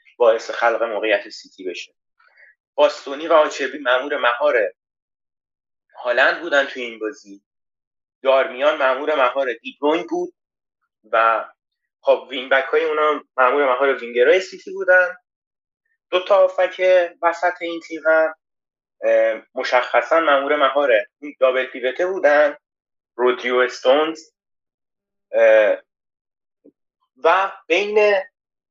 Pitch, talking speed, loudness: 165 Hz, 100 wpm, -18 LUFS